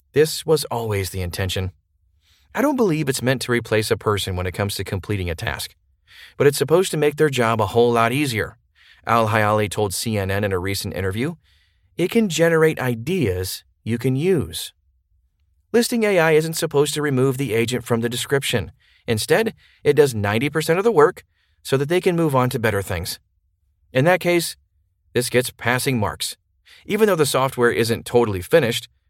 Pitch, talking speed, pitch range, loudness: 120 Hz, 180 wpm, 95-150 Hz, -20 LUFS